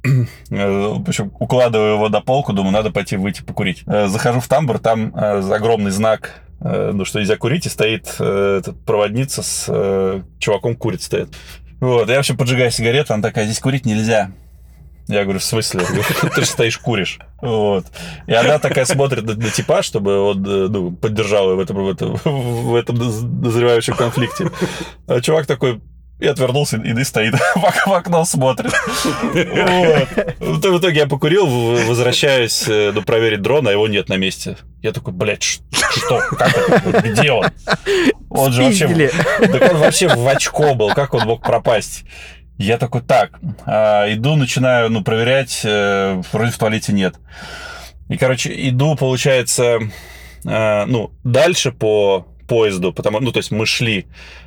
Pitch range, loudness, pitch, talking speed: 100-130 Hz, -16 LUFS, 115 Hz, 140 wpm